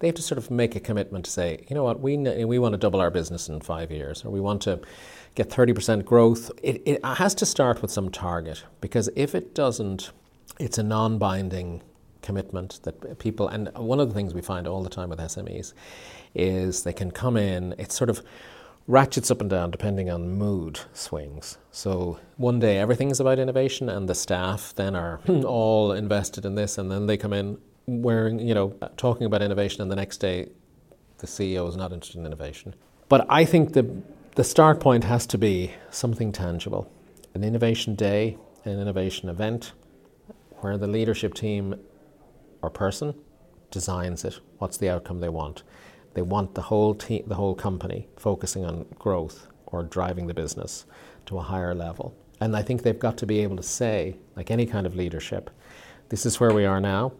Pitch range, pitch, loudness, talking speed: 90-115 Hz, 100 Hz, -25 LUFS, 195 wpm